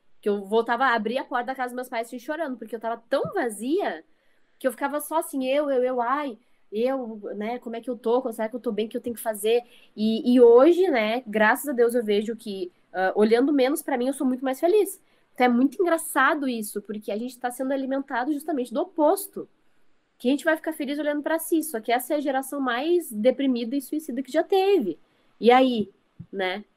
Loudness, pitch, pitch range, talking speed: -24 LUFS, 255 Hz, 230-295 Hz, 235 wpm